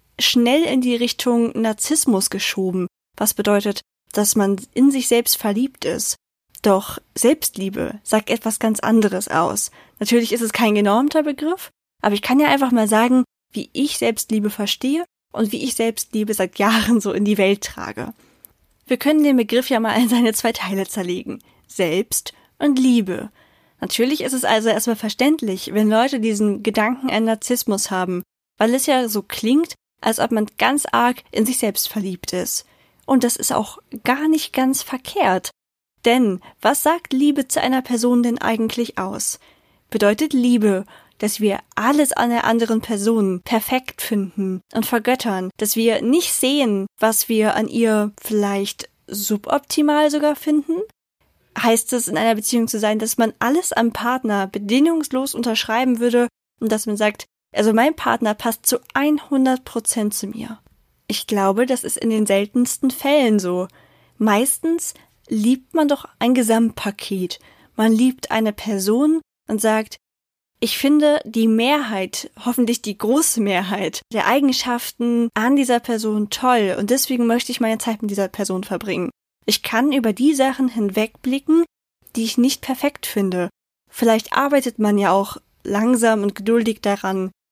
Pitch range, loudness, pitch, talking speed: 210-255 Hz, -19 LUFS, 230 Hz, 155 wpm